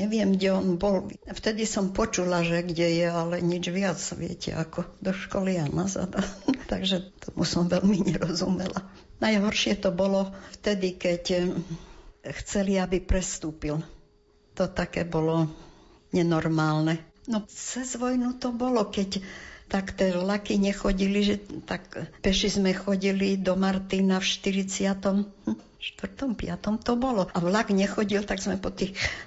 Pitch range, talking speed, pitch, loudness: 175-200 Hz, 135 wpm, 190 Hz, -27 LUFS